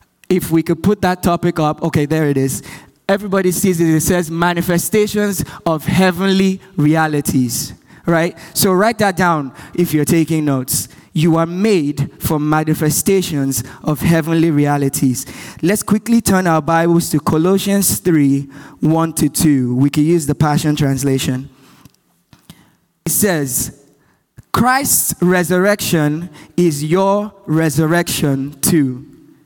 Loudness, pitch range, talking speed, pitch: -15 LUFS, 150-180 Hz, 125 wpm, 165 Hz